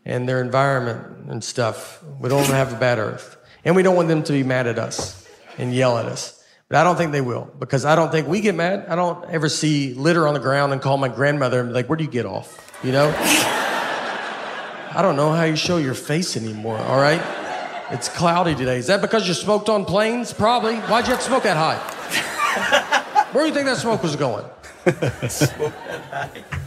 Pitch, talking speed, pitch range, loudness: 155 Hz, 220 wpm, 130-180 Hz, -20 LUFS